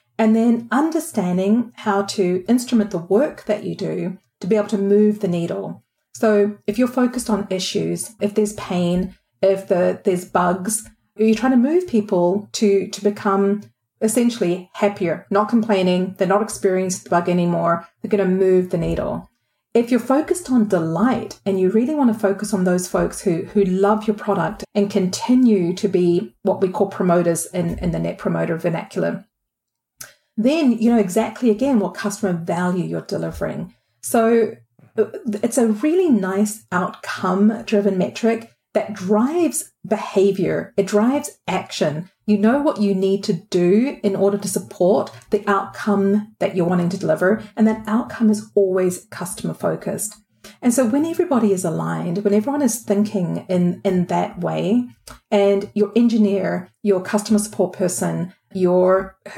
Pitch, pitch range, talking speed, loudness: 205 Hz, 185-220 Hz, 160 wpm, -19 LUFS